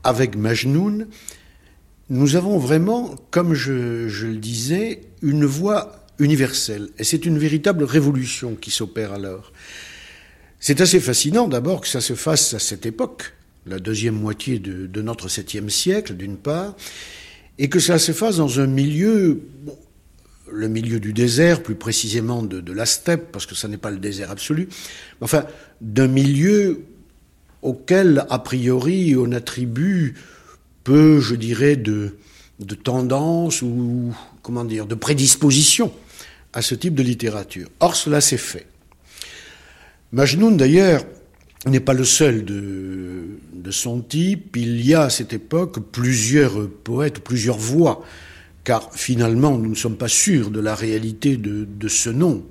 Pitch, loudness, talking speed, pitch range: 125 Hz, -19 LUFS, 150 wpm, 110-150 Hz